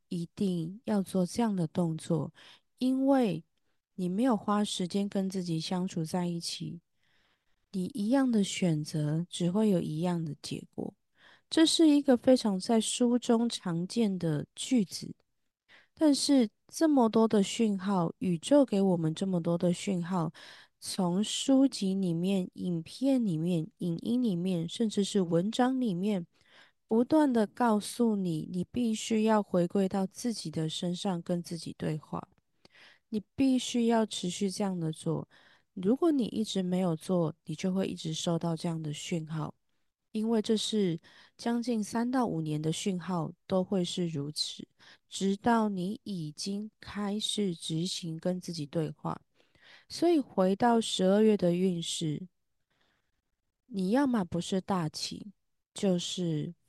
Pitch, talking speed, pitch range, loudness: 190 Hz, 205 characters per minute, 170-225 Hz, -30 LUFS